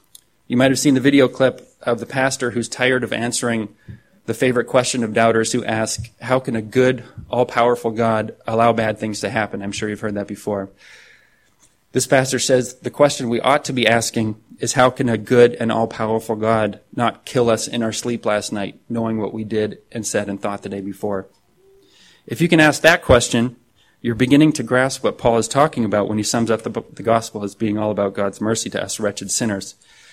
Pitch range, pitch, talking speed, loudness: 110-125 Hz, 115 Hz, 215 wpm, -19 LUFS